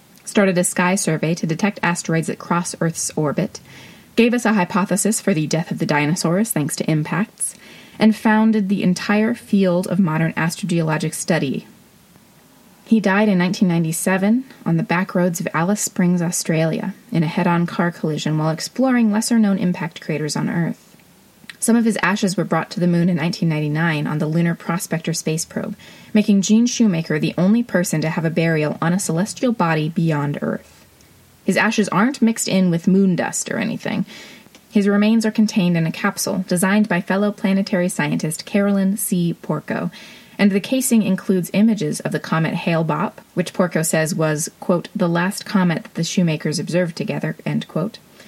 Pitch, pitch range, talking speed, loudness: 185 Hz, 165-210 Hz, 175 wpm, -19 LUFS